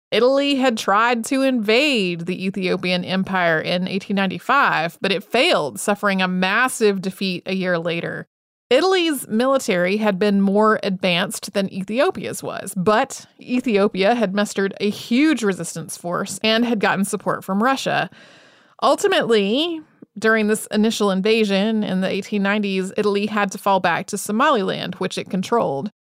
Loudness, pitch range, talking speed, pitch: -19 LUFS, 190-225 Hz, 140 wpm, 205 Hz